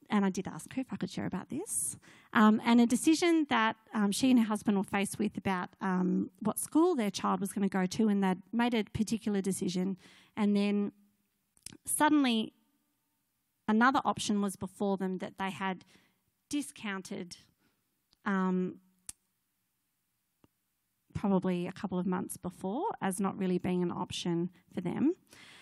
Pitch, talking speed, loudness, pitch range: 200 Hz, 160 wpm, -32 LUFS, 185-225 Hz